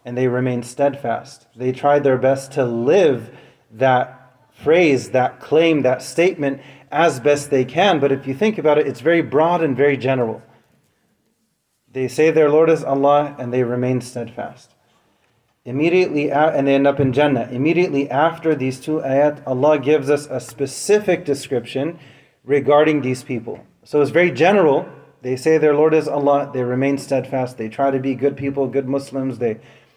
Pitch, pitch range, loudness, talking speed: 140 Hz, 130-150 Hz, -18 LUFS, 170 wpm